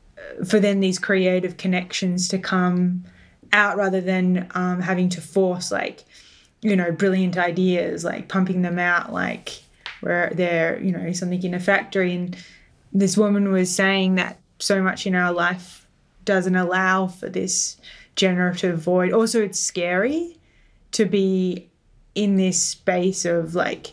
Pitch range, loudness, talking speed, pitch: 180-195 Hz, -21 LUFS, 150 wpm, 185 Hz